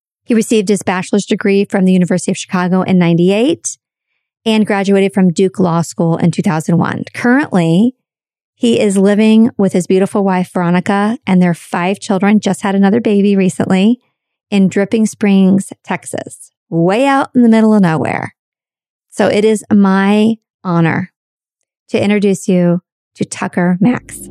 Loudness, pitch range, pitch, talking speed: -13 LUFS, 185-215 Hz, 195 Hz, 150 wpm